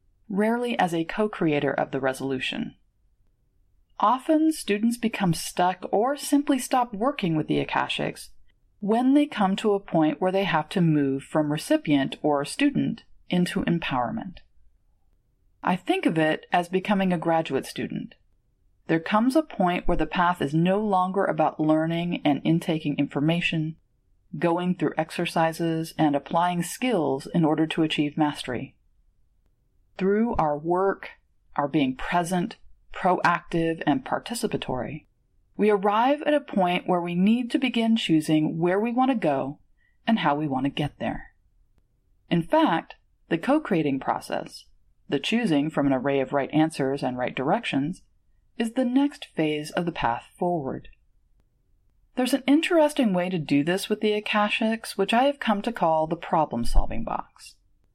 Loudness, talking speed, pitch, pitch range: -25 LUFS, 155 wpm, 170 Hz, 145-210 Hz